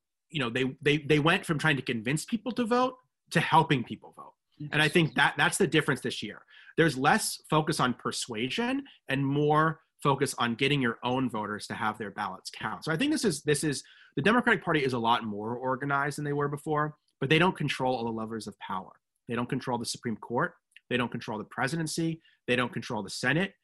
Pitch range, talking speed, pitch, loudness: 125-160 Hz, 225 wpm, 140 Hz, -29 LUFS